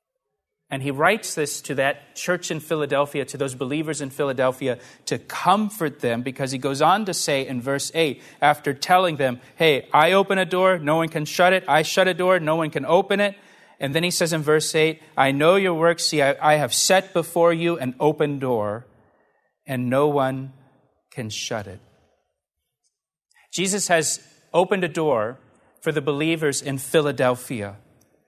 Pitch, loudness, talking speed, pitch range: 150 Hz, -21 LUFS, 180 wpm, 135-170 Hz